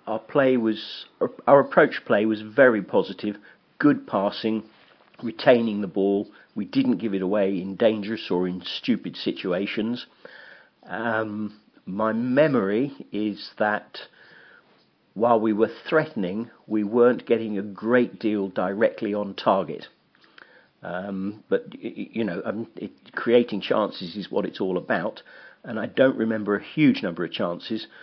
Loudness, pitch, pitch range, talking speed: -24 LUFS, 110 Hz, 100-115 Hz, 140 wpm